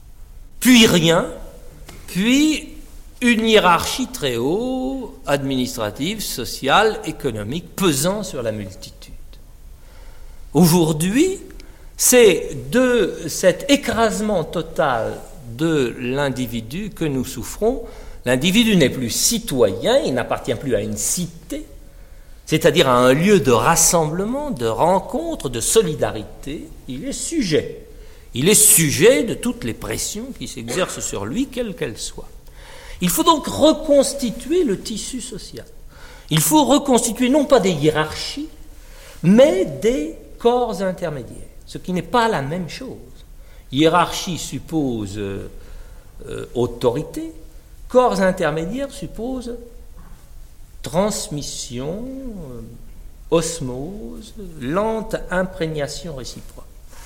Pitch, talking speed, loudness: 170 Hz, 105 wpm, -18 LUFS